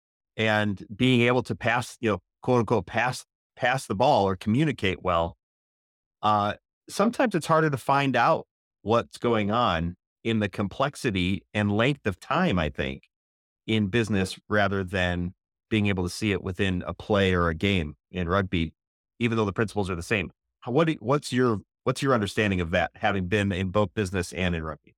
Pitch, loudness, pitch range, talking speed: 105 Hz, -26 LUFS, 90-120 Hz, 180 wpm